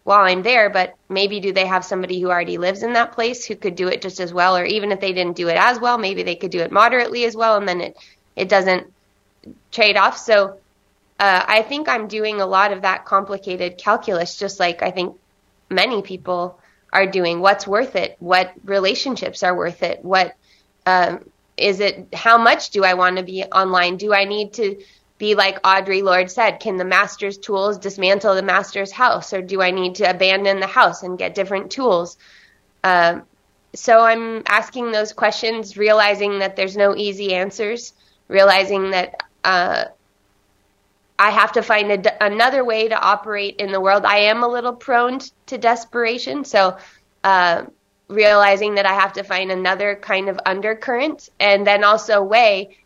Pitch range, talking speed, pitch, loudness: 185-215 Hz, 190 wpm, 195 Hz, -17 LUFS